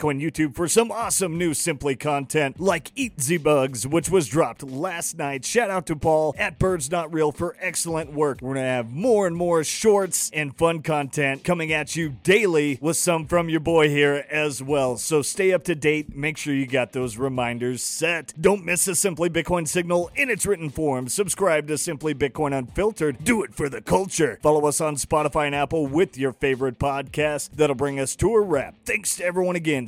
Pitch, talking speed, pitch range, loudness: 155 Hz, 205 wpm, 145-175 Hz, -23 LUFS